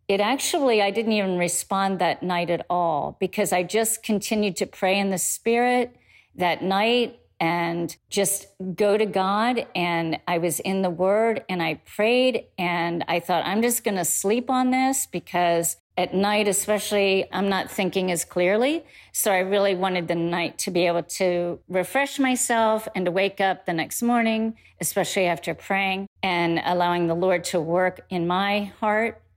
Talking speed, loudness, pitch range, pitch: 175 wpm, -23 LUFS, 175-215 Hz, 190 Hz